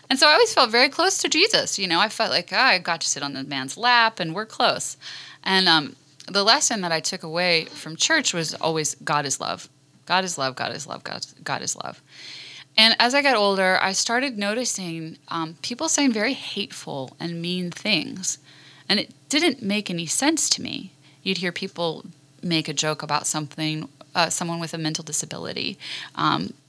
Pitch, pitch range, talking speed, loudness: 180 Hz, 155-230 Hz, 200 wpm, -22 LUFS